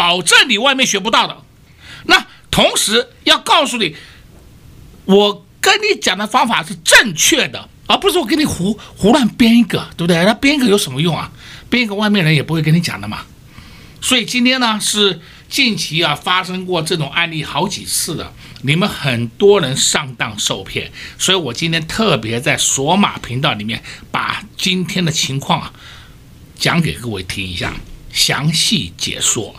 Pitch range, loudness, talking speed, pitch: 150-215 Hz, -14 LUFS, 255 characters per minute, 180 Hz